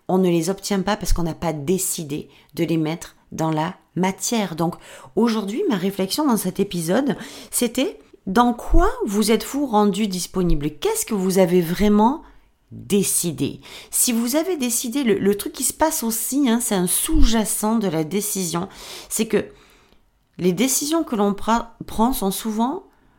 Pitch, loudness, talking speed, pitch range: 205 Hz, -21 LUFS, 165 wpm, 185-235 Hz